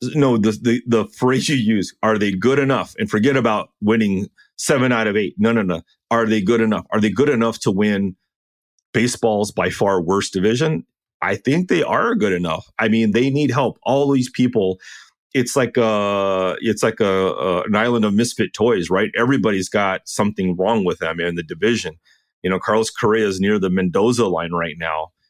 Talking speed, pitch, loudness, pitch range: 200 wpm, 105 Hz, -19 LUFS, 95-115 Hz